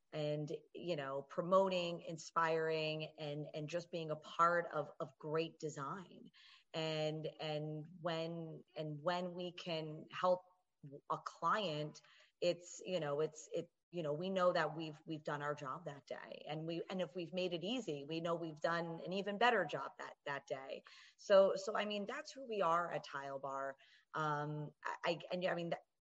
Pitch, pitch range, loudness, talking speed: 165 Hz, 155-180 Hz, -41 LUFS, 180 wpm